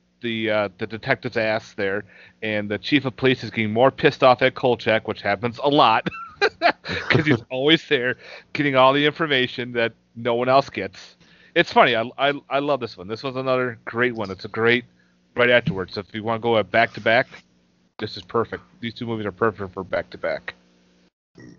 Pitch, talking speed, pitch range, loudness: 115 Hz, 205 wpm, 105-130 Hz, -21 LUFS